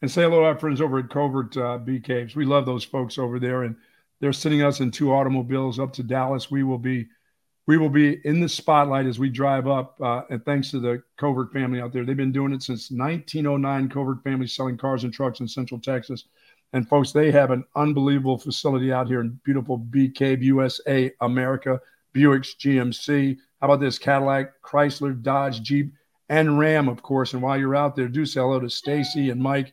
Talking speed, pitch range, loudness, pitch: 210 wpm, 130-140 Hz, -23 LUFS, 135 Hz